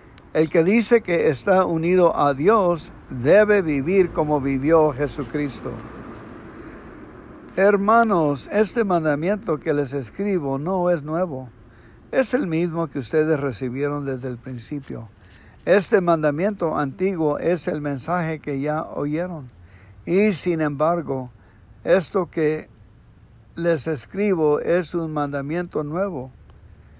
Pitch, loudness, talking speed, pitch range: 155 Hz, -21 LUFS, 115 wpm, 135-180 Hz